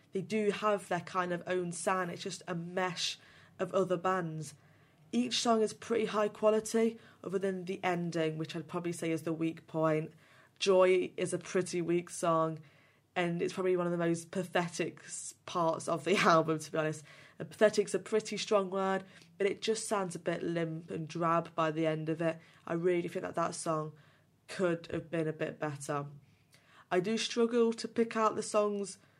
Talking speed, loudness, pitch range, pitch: 195 wpm, -33 LUFS, 160-195 Hz, 175 Hz